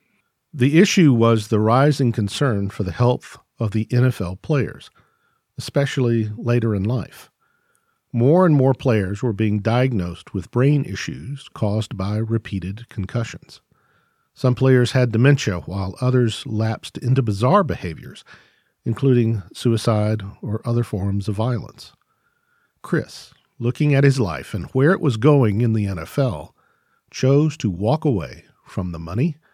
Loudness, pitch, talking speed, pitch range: -20 LUFS, 120 Hz, 140 wpm, 105-140 Hz